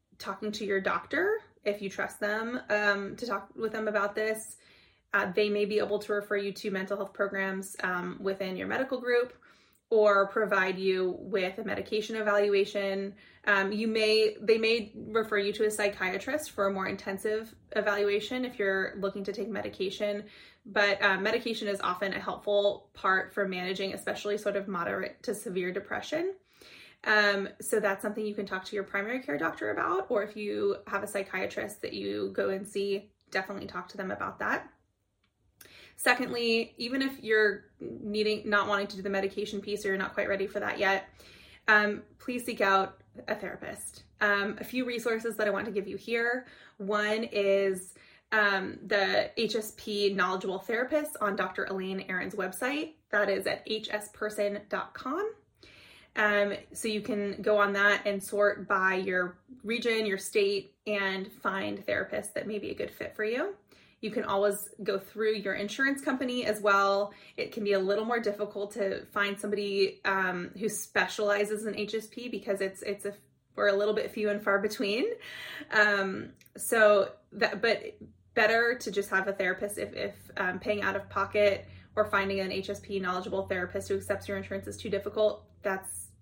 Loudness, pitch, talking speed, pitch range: -30 LUFS, 205 Hz, 175 wpm, 195-215 Hz